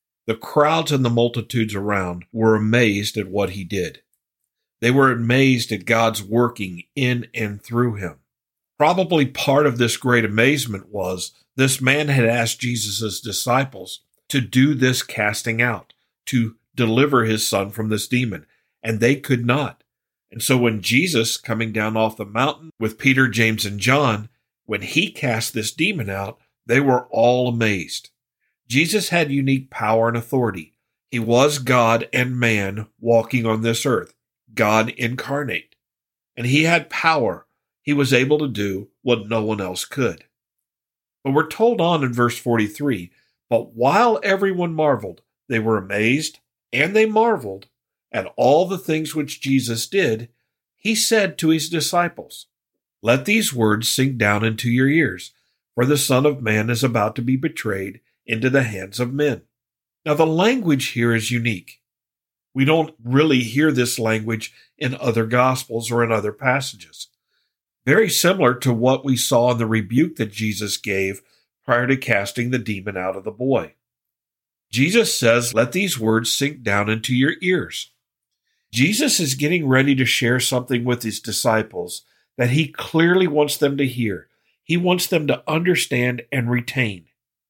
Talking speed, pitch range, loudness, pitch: 160 wpm, 110-140 Hz, -19 LUFS, 120 Hz